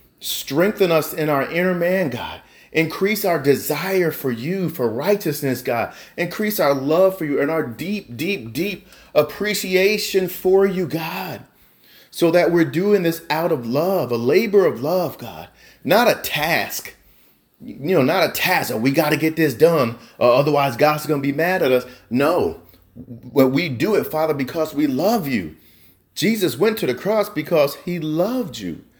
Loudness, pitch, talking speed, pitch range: -19 LUFS, 160 Hz, 175 wpm, 140-190 Hz